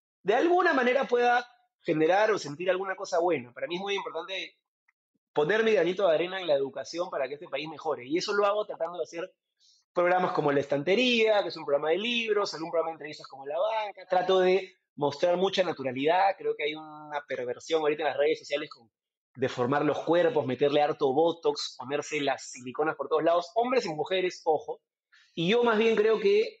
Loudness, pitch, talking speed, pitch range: -28 LUFS, 175 Hz, 205 wpm, 150-210 Hz